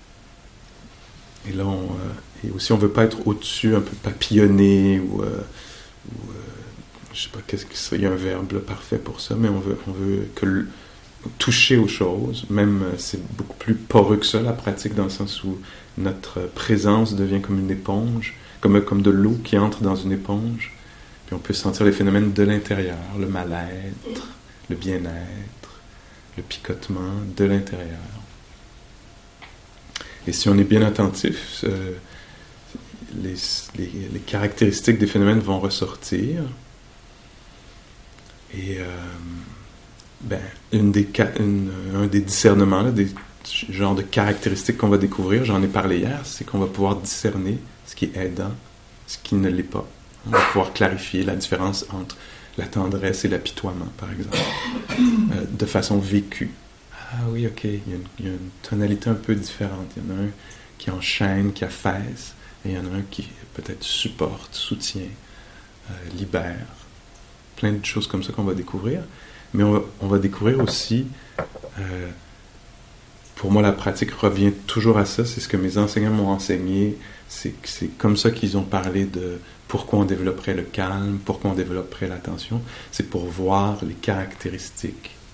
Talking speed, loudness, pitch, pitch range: 170 wpm, -22 LUFS, 100 Hz, 95-110 Hz